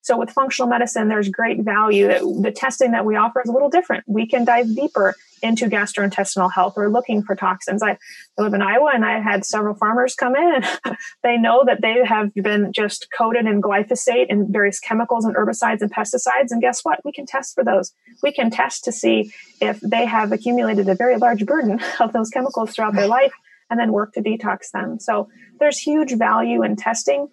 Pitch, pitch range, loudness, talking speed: 225 Hz, 200-245 Hz, -19 LUFS, 205 wpm